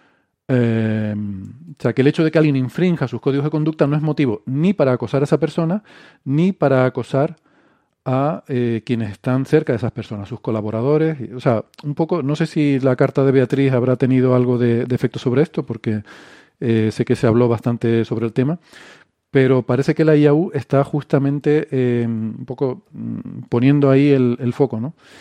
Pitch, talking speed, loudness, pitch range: 135 Hz, 195 wpm, -18 LUFS, 120-150 Hz